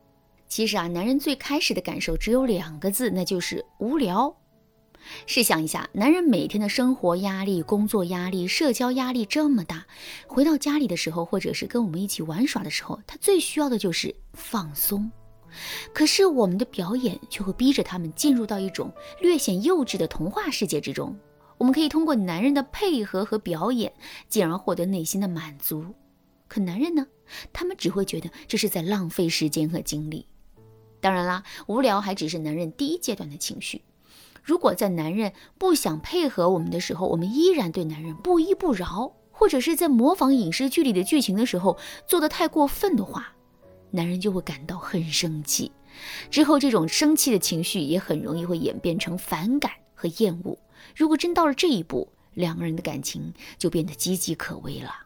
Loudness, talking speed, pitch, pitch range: -24 LUFS, 290 characters per minute, 205 Hz, 170-275 Hz